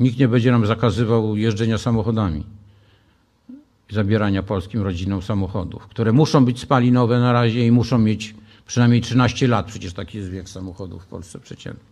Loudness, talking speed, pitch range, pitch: -19 LUFS, 155 wpm, 100-120 Hz, 110 Hz